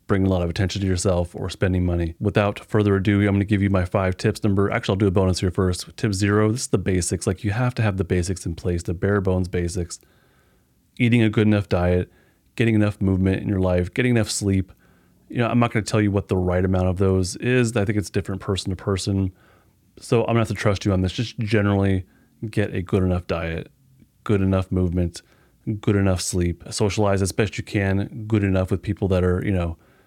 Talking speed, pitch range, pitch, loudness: 240 wpm, 90-105 Hz, 100 Hz, -22 LUFS